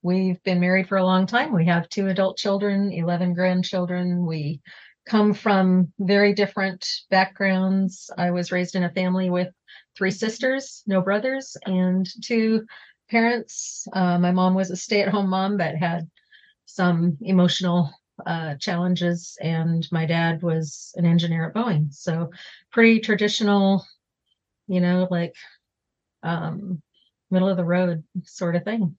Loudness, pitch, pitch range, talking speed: -22 LUFS, 185 Hz, 175-200 Hz, 145 wpm